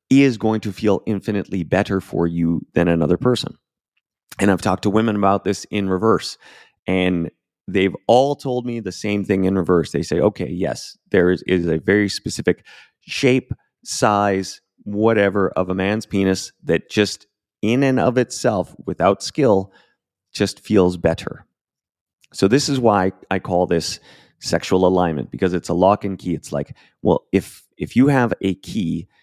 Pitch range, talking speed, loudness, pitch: 90-110 Hz, 170 wpm, -19 LUFS, 95 Hz